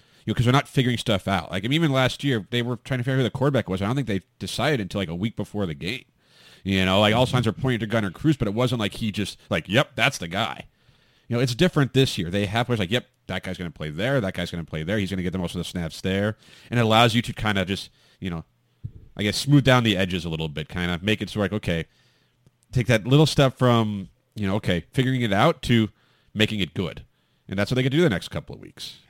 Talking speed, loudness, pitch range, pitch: 295 wpm, -23 LUFS, 95-125 Hz, 110 Hz